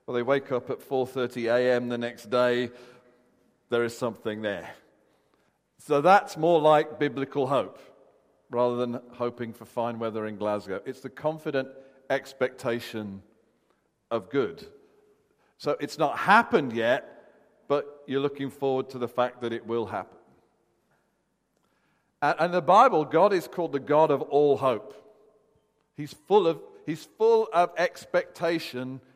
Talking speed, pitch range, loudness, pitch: 140 wpm, 120-155 Hz, -26 LUFS, 130 Hz